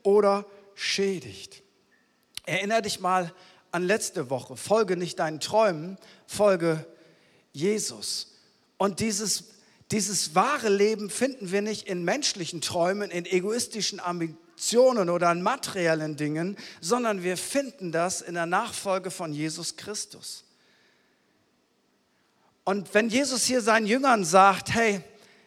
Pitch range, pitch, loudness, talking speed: 175-215 Hz, 195 Hz, -26 LUFS, 120 wpm